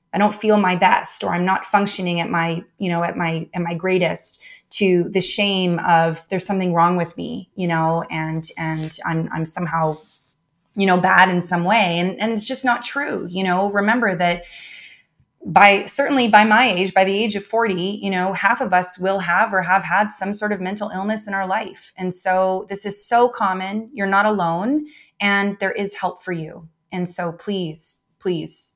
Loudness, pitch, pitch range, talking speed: -18 LUFS, 190 Hz, 175-205 Hz, 200 wpm